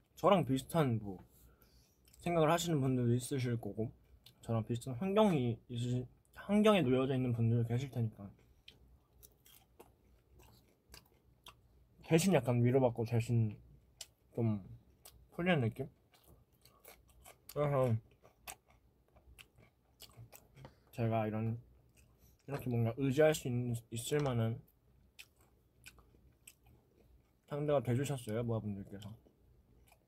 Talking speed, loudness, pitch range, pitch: 185 characters per minute, -35 LUFS, 110-135 Hz, 120 Hz